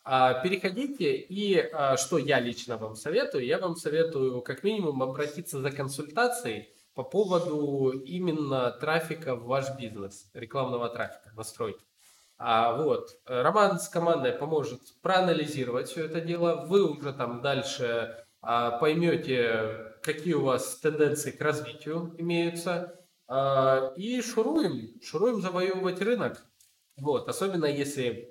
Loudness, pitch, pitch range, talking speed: -29 LUFS, 150 Hz, 130-180 Hz, 115 wpm